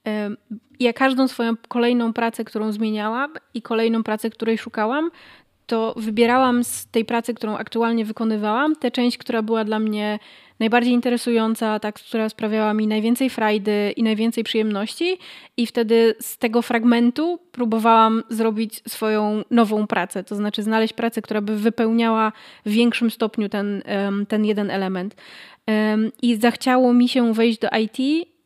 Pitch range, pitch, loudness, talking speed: 215-240 Hz, 225 Hz, -21 LUFS, 145 wpm